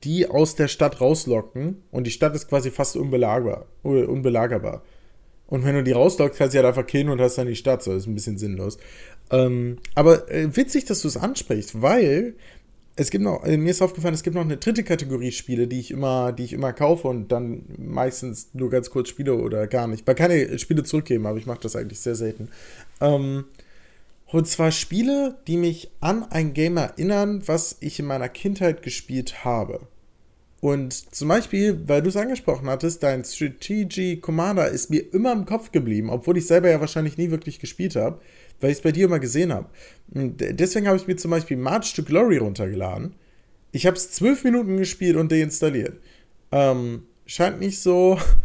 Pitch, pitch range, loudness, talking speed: 150 Hz, 125-175 Hz, -22 LUFS, 195 wpm